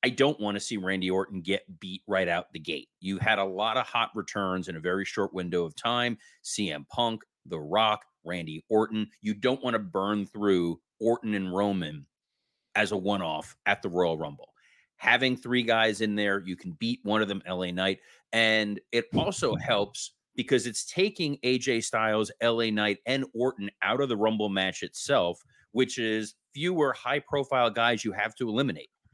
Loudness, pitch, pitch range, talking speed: -28 LUFS, 110 Hz, 95-120 Hz, 190 wpm